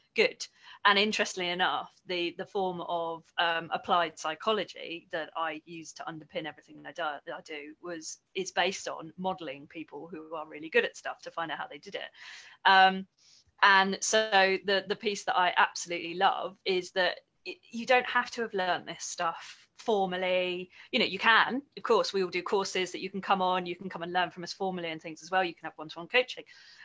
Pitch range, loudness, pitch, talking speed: 165-195 Hz, -29 LUFS, 180 Hz, 215 wpm